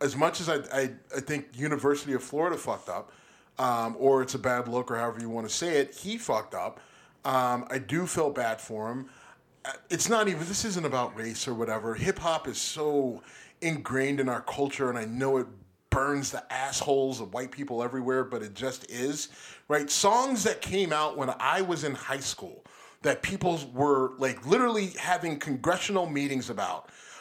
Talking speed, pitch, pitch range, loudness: 190 wpm, 135 Hz, 125-160 Hz, -29 LUFS